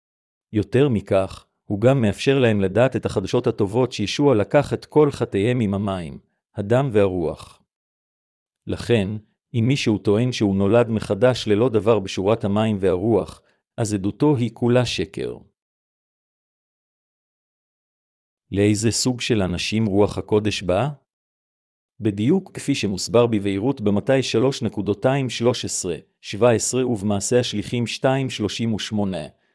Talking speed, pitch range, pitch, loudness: 105 wpm, 100-125 Hz, 110 Hz, -21 LUFS